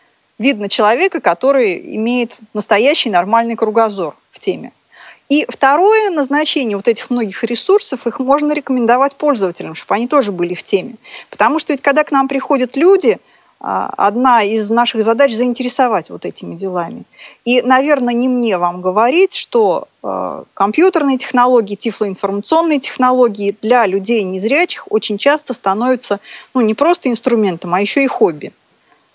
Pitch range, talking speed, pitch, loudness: 220-285 Hz, 140 wpm, 245 Hz, -14 LUFS